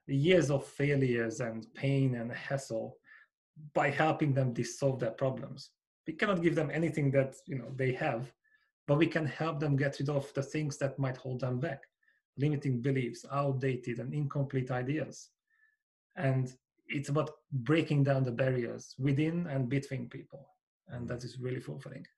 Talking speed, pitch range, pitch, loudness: 160 wpm, 130-155 Hz, 140 Hz, -33 LUFS